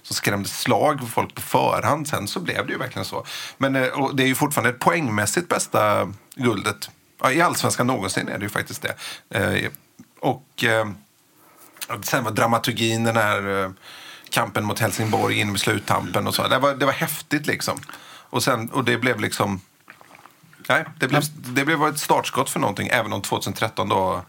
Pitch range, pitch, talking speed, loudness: 110-135 Hz, 120 Hz, 175 wpm, -22 LUFS